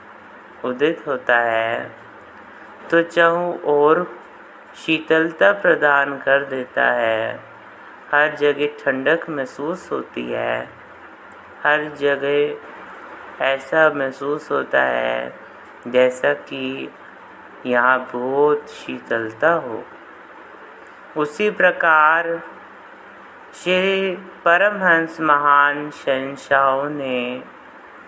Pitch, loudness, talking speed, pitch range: 145 Hz, -19 LUFS, 75 wpm, 130-160 Hz